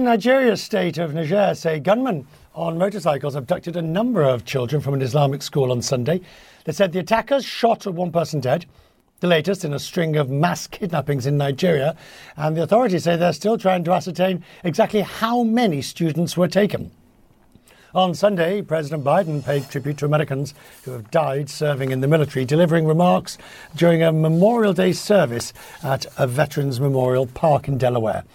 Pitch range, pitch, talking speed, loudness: 140-185 Hz, 165 Hz, 175 wpm, -20 LUFS